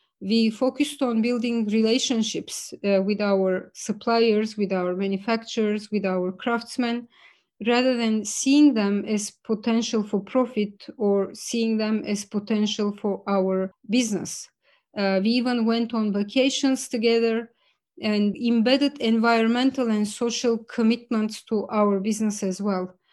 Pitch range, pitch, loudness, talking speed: 205-235 Hz, 220 Hz, -24 LUFS, 125 wpm